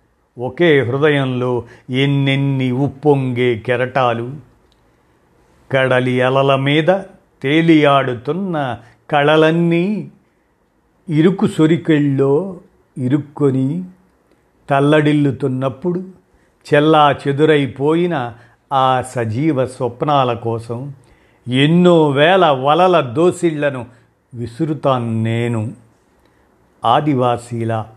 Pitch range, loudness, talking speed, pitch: 125-155 Hz, -15 LUFS, 60 wpm, 140 Hz